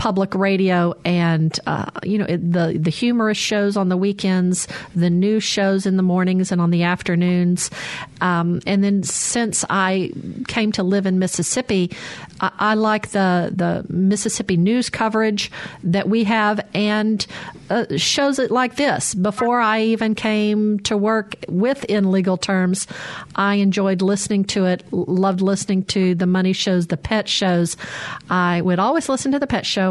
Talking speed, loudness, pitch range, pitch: 165 wpm, -19 LUFS, 180-215 Hz, 195 Hz